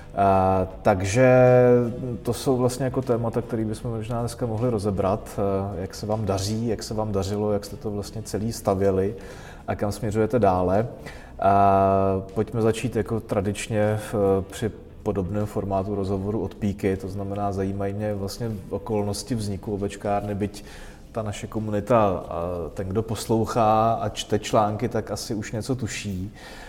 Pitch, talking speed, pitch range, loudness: 105 Hz, 155 wpm, 100-110 Hz, -24 LUFS